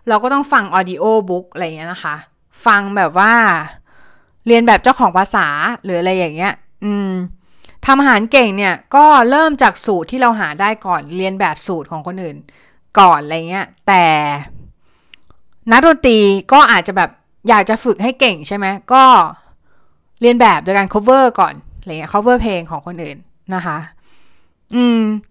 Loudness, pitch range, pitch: -12 LUFS, 180-240 Hz, 200 Hz